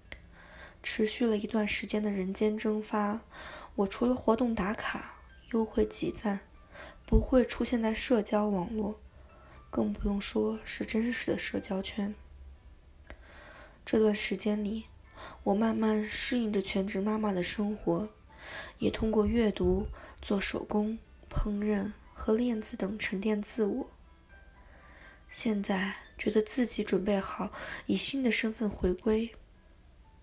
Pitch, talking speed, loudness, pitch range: 210 Hz, 190 characters per minute, -30 LUFS, 190-220 Hz